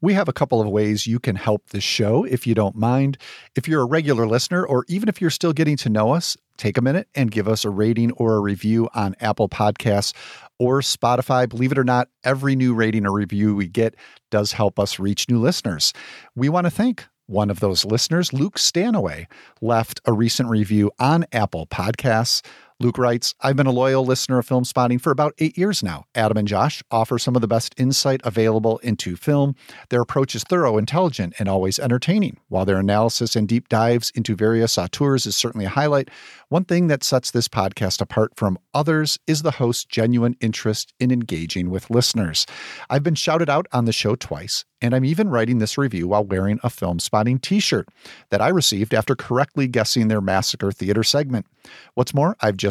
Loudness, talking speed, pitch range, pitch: -20 LUFS, 205 wpm, 105-135 Hz, 120 Hz